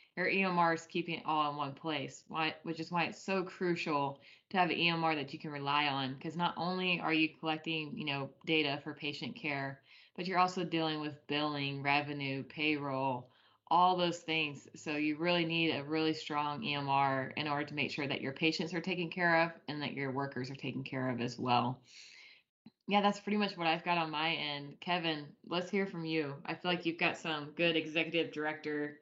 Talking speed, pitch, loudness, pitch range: 210 wpm, 155 Hz, -34 LUFS, 145-170 Hz